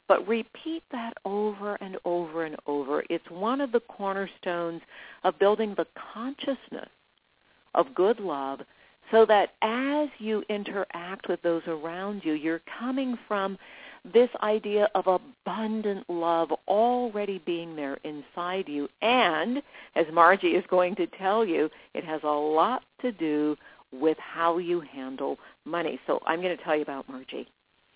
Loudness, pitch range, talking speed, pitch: -28 LUFS, 165-220 Hz, 150 wpm, 190 Hz